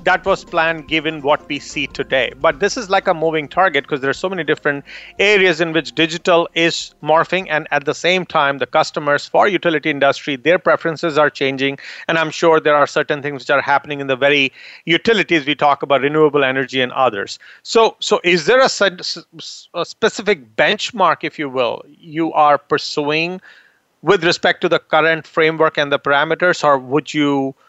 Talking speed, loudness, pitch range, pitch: 195 wpm, -16 LUFS, 145-170 Hz, 155 Hz